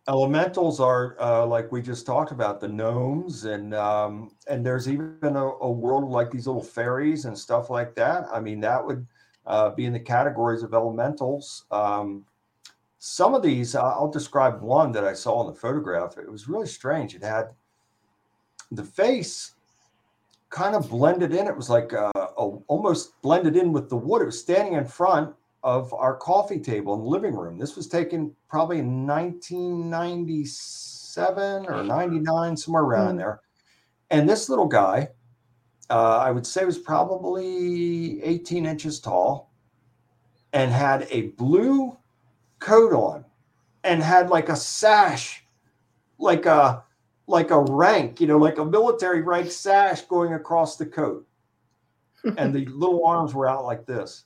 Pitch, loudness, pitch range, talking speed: 135 Hz, -23 LUFS, 115-165 Hz, 165 wpm